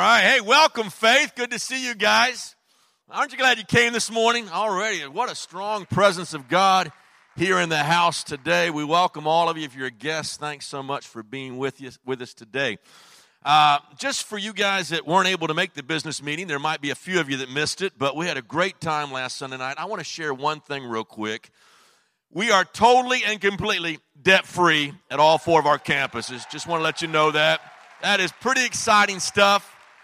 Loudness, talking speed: -21 LUFS, 225 wpm